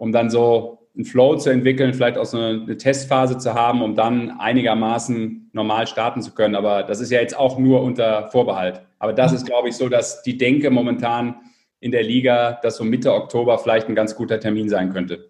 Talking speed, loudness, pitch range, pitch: 210 wpm, -19 LUFS, 110-125 Hz, 120 Hz